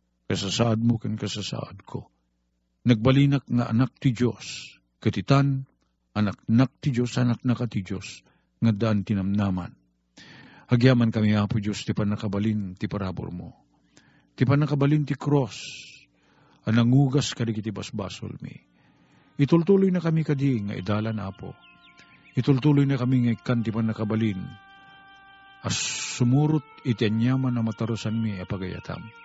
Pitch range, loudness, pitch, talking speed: 105-140 Hz, -25 LUFS, 115 Hz, 125 wpm